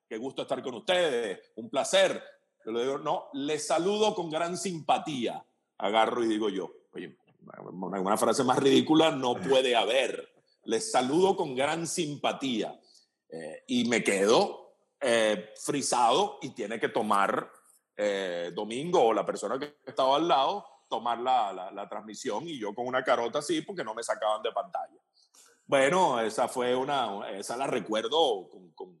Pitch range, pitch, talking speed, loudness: 110-175 Hz, 130 Hz, 160 wpm, -28 LUFS